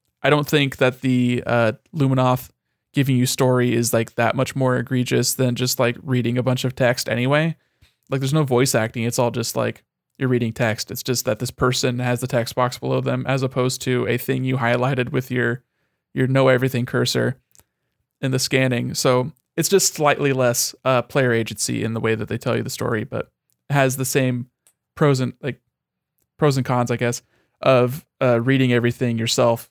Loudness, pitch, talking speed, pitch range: -20 LUFS, 125 Hz, 200 wpm, 120-130 Hz